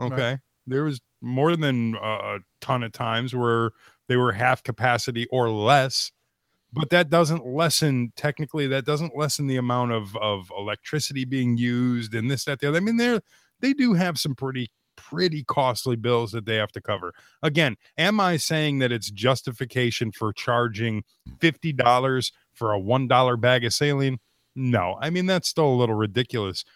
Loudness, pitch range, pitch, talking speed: -24 LUFS, 120-150 Hz, 125 Hz, 170 wpm